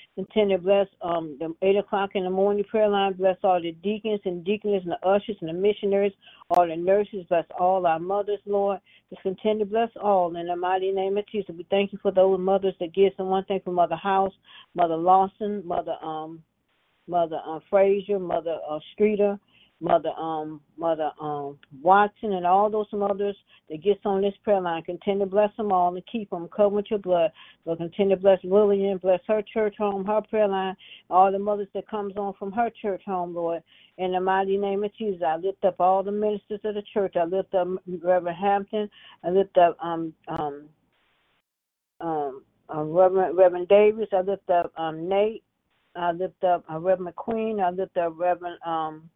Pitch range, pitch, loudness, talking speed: 175-205 Hz, 190 Hz, -25 LUFS, 200 wpm